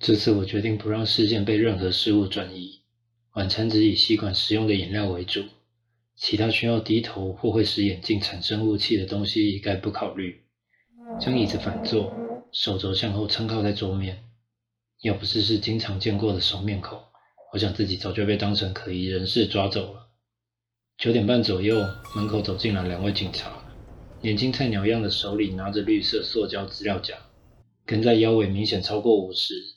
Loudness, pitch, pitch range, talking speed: -24 LUFS, 105 Hz, 100-115 Hz, 270 characters per minute